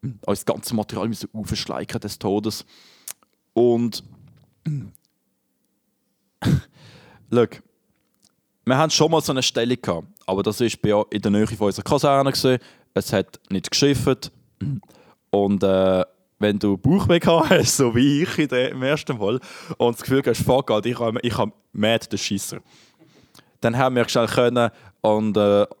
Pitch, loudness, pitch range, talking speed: 115 Hz, -21 LUFS, 105-135 Hz, 135 wpm